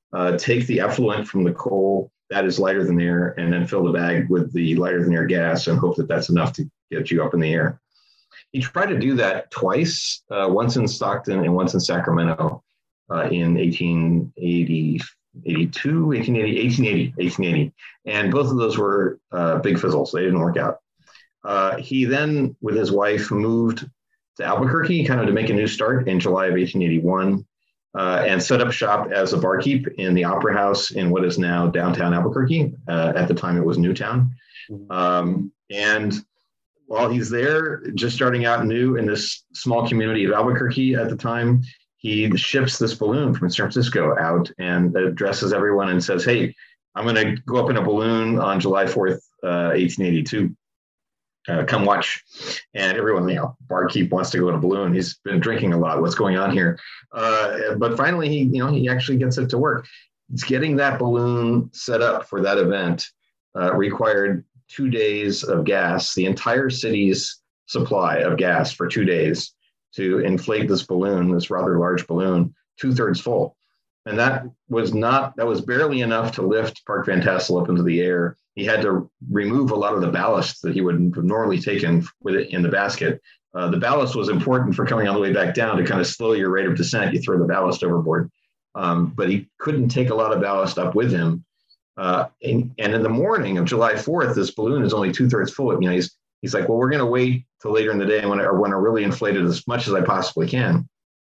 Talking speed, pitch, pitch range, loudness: 205 wpm, 105 Hz, 90-125 Hz, -21 LUFS